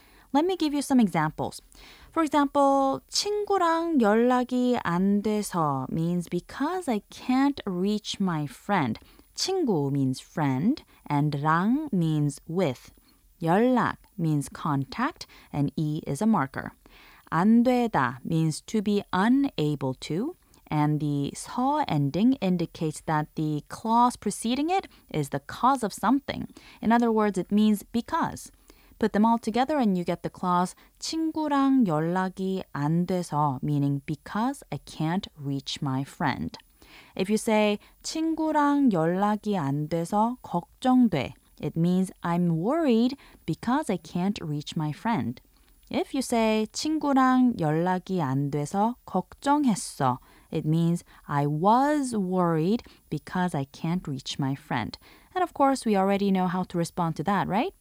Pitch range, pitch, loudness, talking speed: 155-250 Hz, 195 Hz, -26 LUFS, 135 wpm